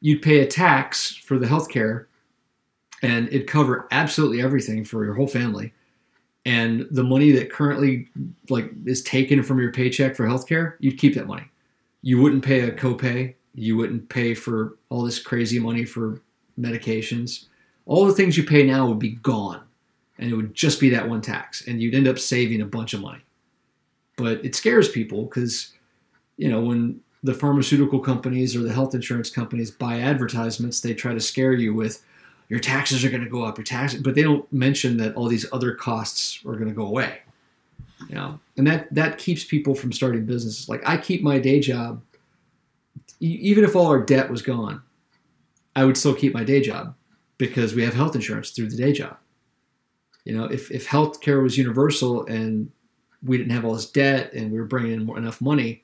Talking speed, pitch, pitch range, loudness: 200 wpm, 130 Hz, 115-140 Hz, -22 LUFS